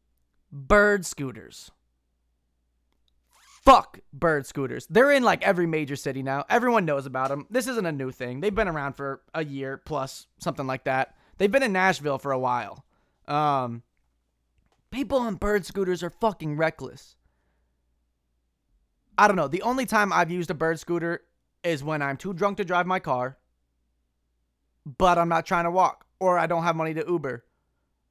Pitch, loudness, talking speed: 145 Hz, -25 LUFS, 170 wpm